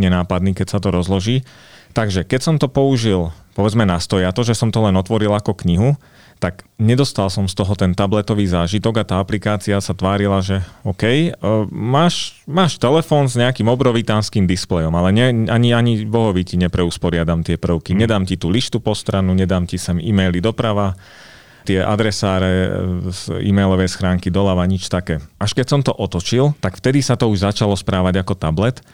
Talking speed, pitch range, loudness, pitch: 175 wpm, 95-115 Hz, -17 LUFS, 100 Hz